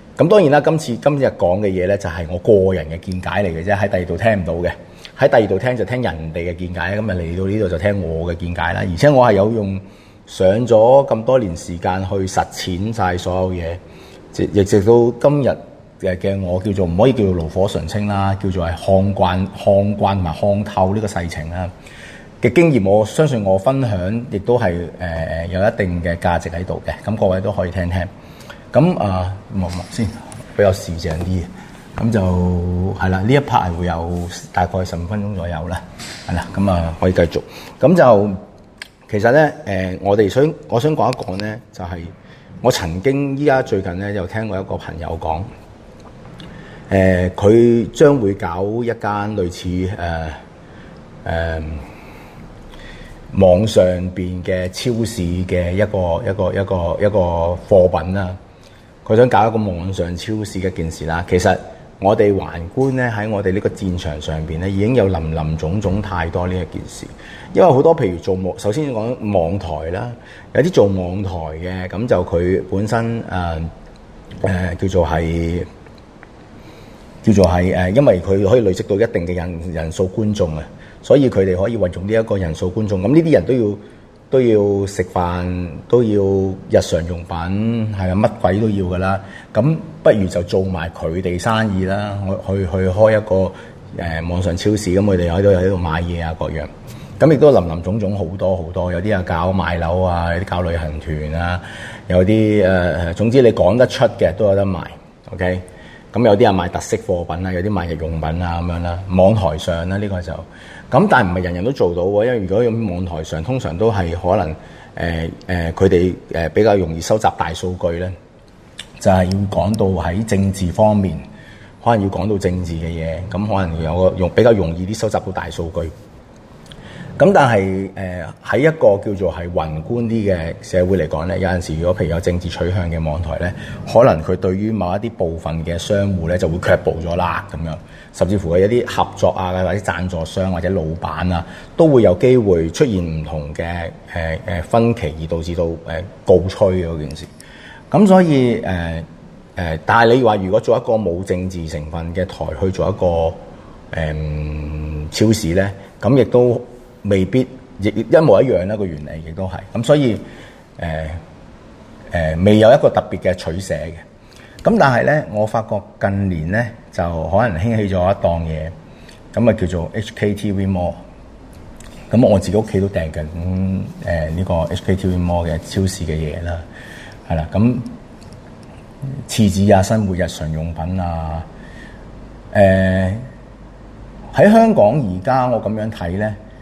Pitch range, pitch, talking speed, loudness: 85-105 Hz, 95 Hz, 260 characters per minute, -17 LUFS